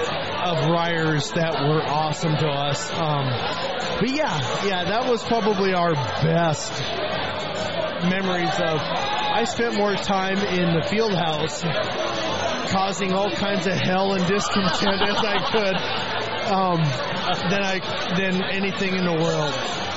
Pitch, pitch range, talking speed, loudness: 180 Hz, 160-195 Hz, 130 wpm, -22 LUFS